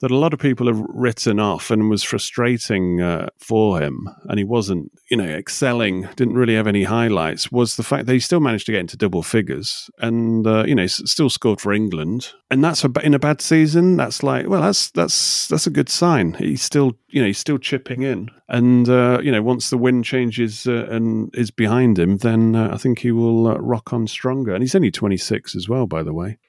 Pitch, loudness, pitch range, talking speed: 120 Hz, -18 LUFS, 110-130 Hz, 230 wpm